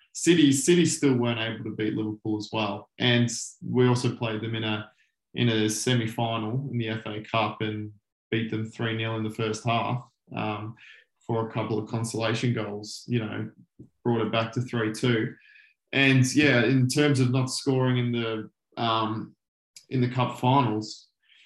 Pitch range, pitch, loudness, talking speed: 110-125 Hz, 115 Hz, -26 LUFS, 170 wpm